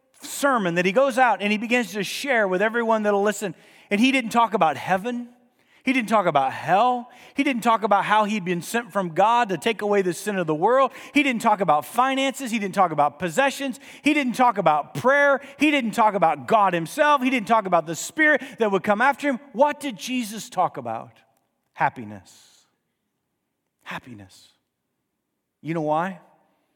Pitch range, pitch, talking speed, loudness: 185-265 Hz, 225 Hz, 190 wpm, -22 LUFS